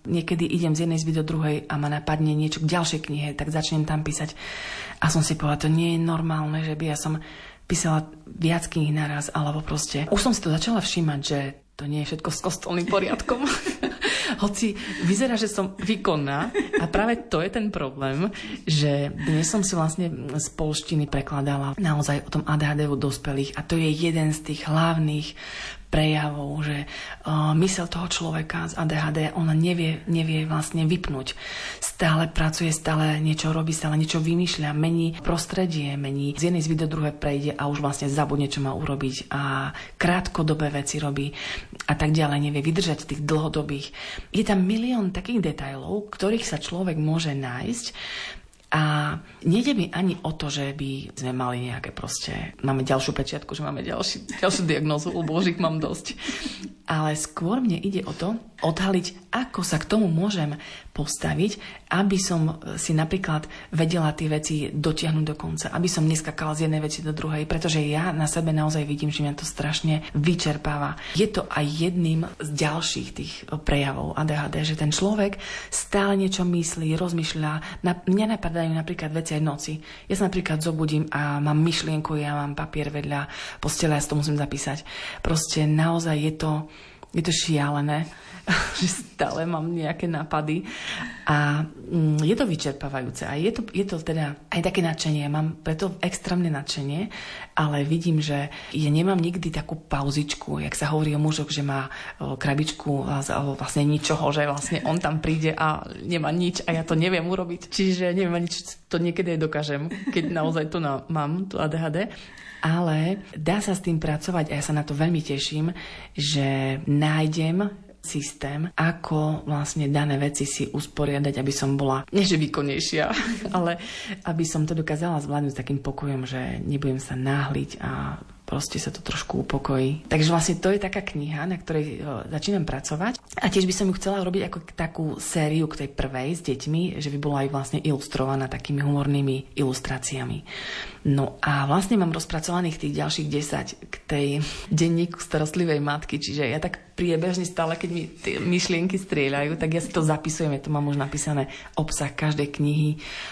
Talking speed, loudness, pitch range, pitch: 170 wpm, -25 LUFS, 145-175 Hz, 155 Hz